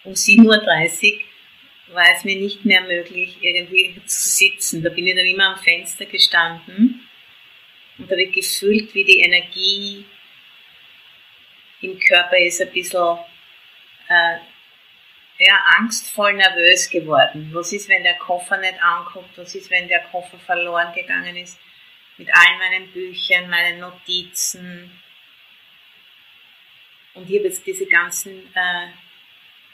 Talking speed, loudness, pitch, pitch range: 130 wpm, -15 LUFS, 185 Hz, 175-195 Hz